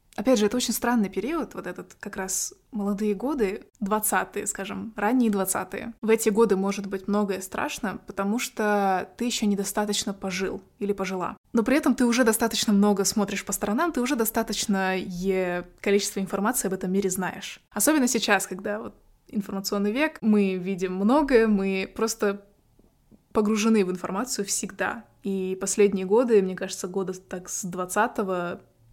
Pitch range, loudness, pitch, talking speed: 195-225 Hz, -25 LUFS, 205 Hz, 155 wpm